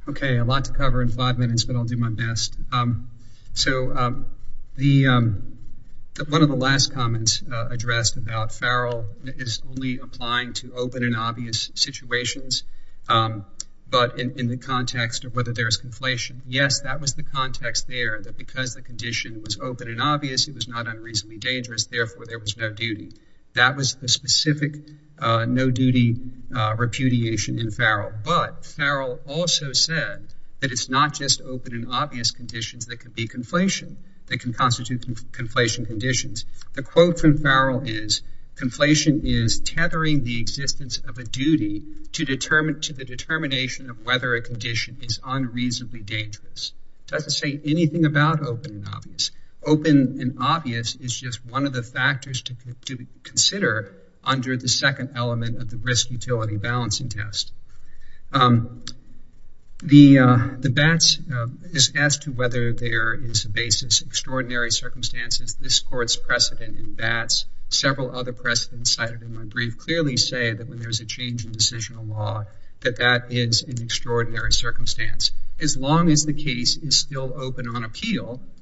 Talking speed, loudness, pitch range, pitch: 160 wpm, -22 LUFS, 115-135 Hz, 125 Hz